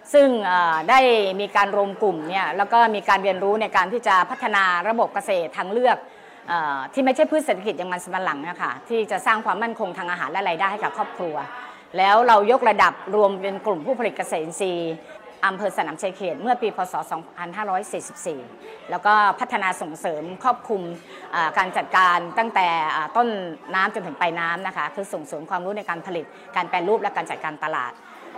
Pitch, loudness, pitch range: 195 Hz, -22 LUFS, 180-220 Hz